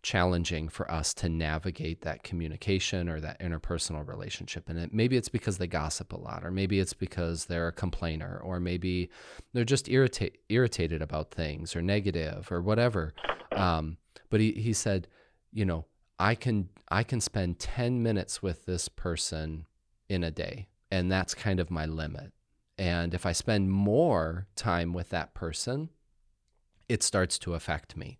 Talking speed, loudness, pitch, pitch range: 170 wpm, -31 LUFS, 90 Hz, 85-105 Hz